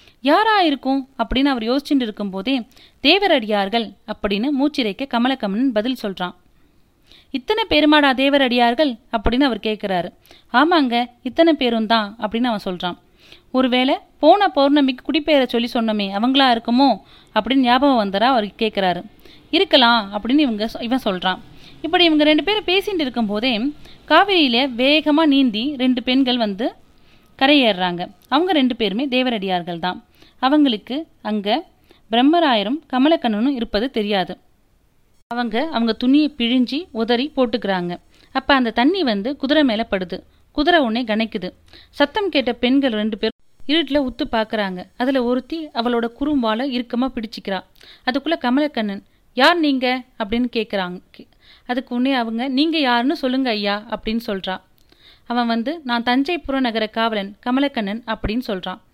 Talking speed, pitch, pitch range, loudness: 120 wpm, 250 Hz, 220-285 Hz, -19 LUFS